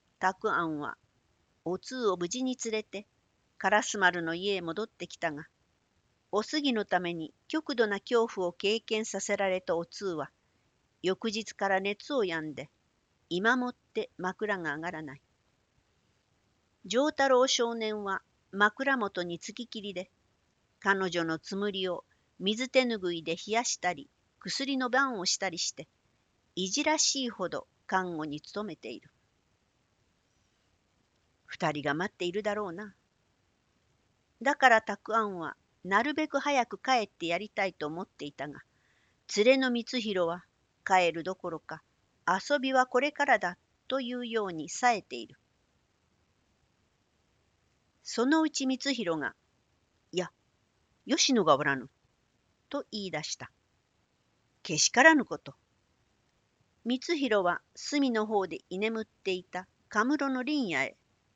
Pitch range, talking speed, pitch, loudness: 170-245 Hz, 235 characters per minute, 200 Hz, -30 LUFS